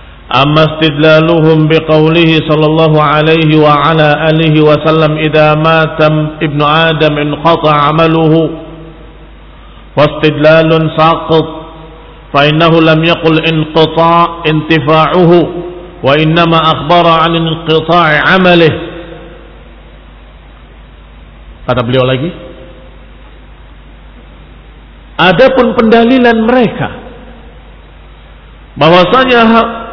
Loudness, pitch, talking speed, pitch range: -7 LUFS, 160 Hz, 70 wpm, 150-165 Hz